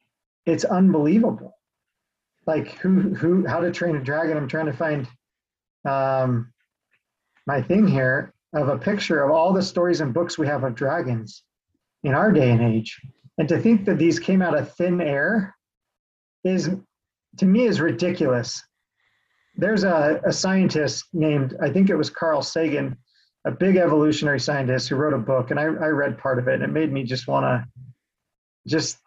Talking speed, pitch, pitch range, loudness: 175 wpm, 155 Hz, 135-175 Hz, -22 LUFS